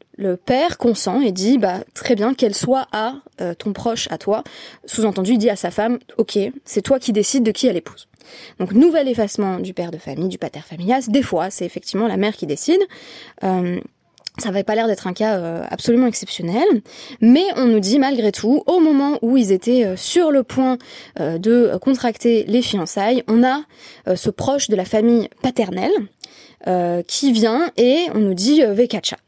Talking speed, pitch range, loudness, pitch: 200 wpm, 195-260 Hz, -18 LUFS, 225 Hz